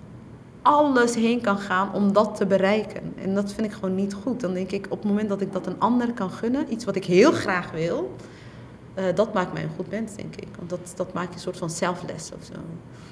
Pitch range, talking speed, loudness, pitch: 185-210 Hz, 240 wpm, -24 LUFS, 195 Hz